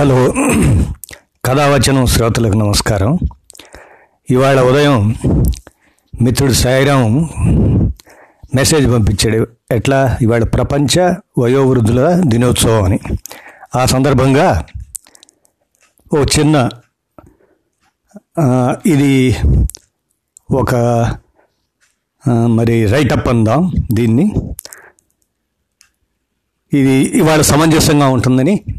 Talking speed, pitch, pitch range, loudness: 65 wpm, 125 Hz, 115-140 Hz, -12 LUFS